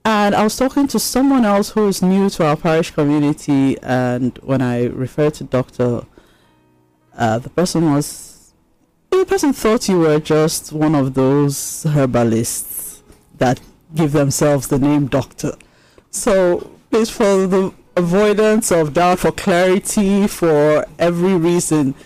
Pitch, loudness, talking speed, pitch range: 160 Hz, -16 LUFS, 140 wpm, 135-195 Hz